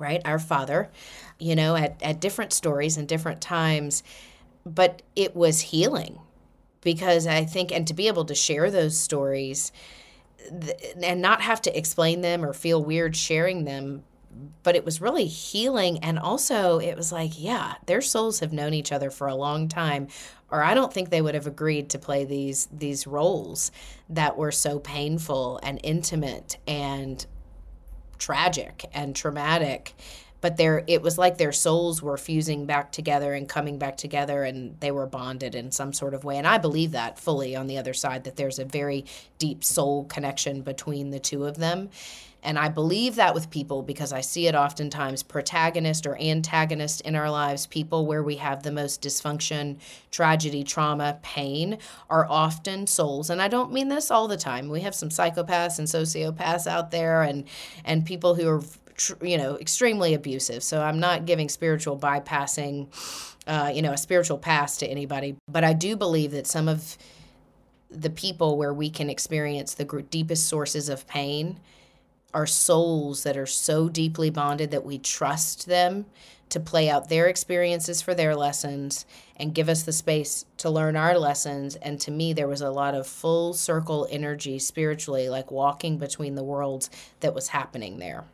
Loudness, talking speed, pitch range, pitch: -25 LUFS, 180 wpm, 140-165 Hz, 155 Hz